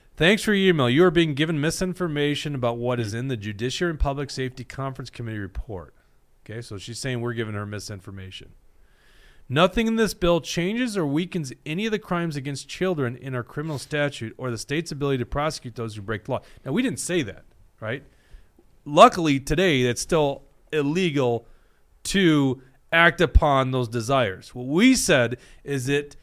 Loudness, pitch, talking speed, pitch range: -23 LUFS, 140 Hz, 180 wpm, 120-170 Hz